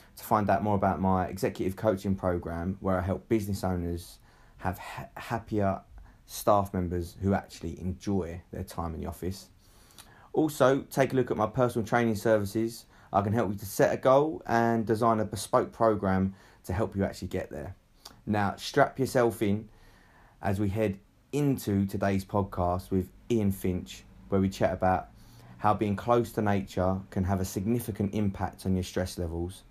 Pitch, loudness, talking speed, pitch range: 100 Hz, -29 LUFS, 175 wpm, 95-115 Hz